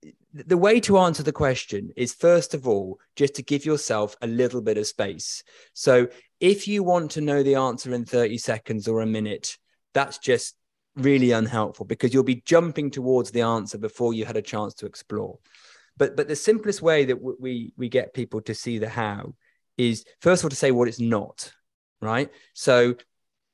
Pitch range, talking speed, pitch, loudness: 115-150 Hz, 195 wpm, 125 Hz, -23 LUFS